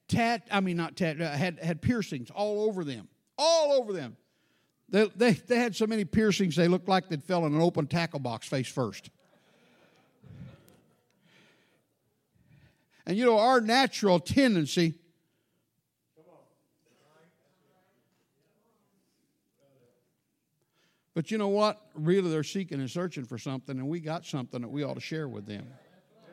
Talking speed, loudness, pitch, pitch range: 140 wpm, -28 LUFS, 170 Hz, 145-210 Hz